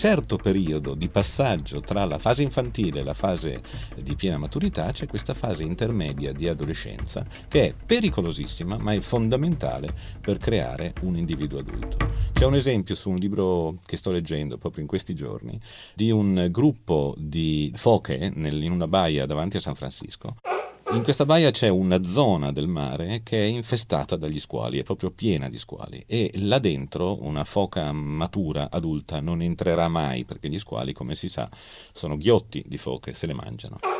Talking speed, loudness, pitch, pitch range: 175 wpm, -25 LUFS, 90 Hz, 75-105 Hz